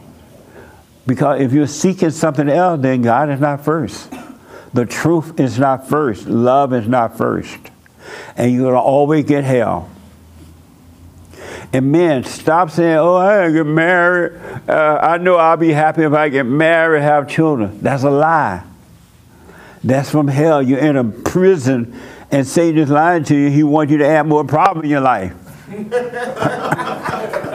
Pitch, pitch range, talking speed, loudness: 145 Hz, 130-160 Hz, 165 wpm, -14 LUFS